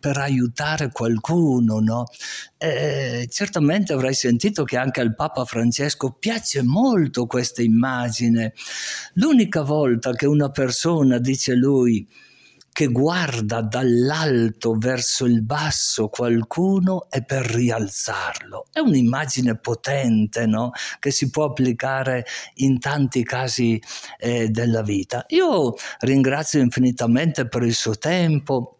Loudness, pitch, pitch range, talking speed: -20 LUFS, 130 Hz, 120-145 Hz, 115 wpm